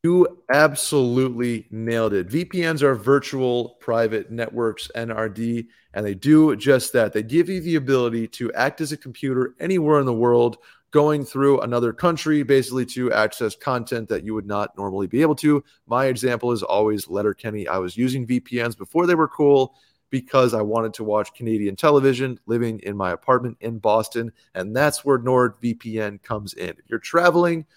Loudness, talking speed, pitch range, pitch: -21 LUFS, 175 wpm, 110-145 Hz, 125 Hz